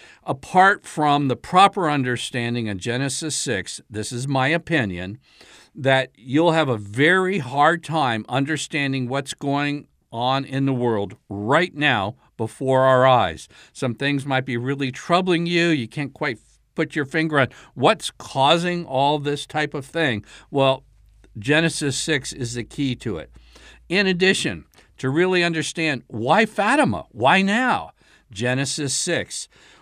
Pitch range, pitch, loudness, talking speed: 125-160 Hz, 140 Hz, -21 LUFS, 145 wpm